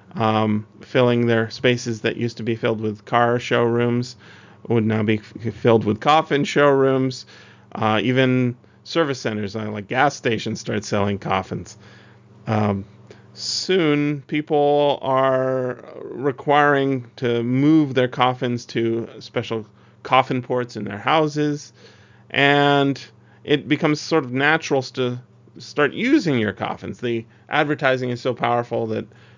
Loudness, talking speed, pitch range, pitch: -20 LUFS, 130 wpm, 115-140 Hz, 125 Hz